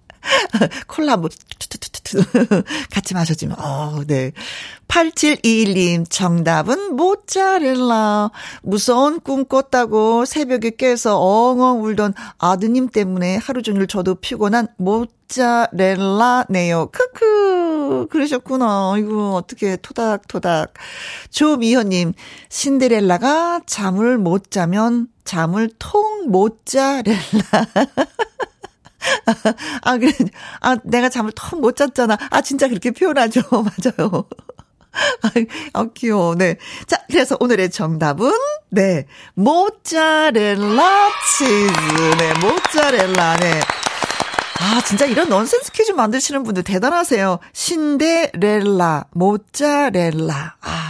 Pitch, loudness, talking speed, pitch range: 230 Hz, -17 LUFS, 210 characters per minute, 190-275 Hz